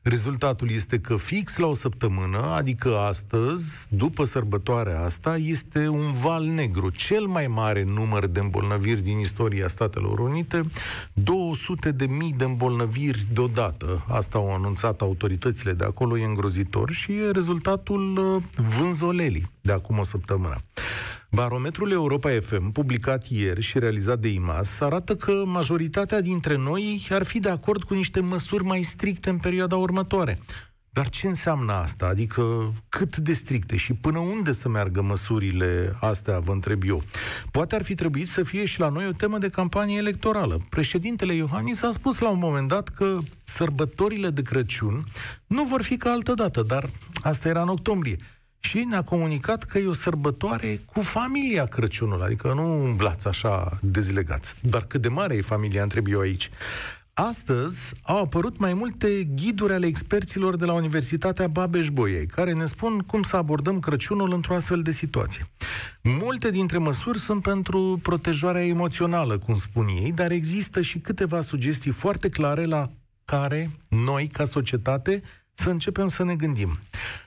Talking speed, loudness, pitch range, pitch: 155 wpm, -25 LUFS, 110-180 Hz, 145 Hz